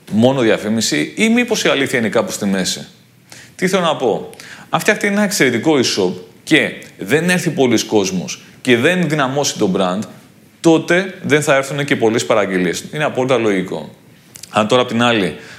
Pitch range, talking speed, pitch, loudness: 110-175 Hz, 170 wpm, 140 Hz, -15 LUFS